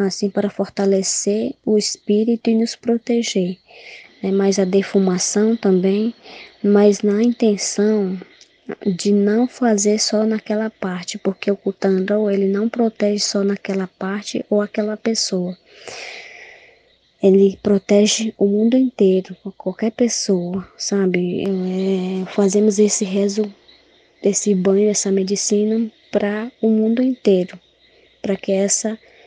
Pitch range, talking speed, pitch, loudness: 195-220 Hz, 115 wpm, 205 Hz, -18 LUFS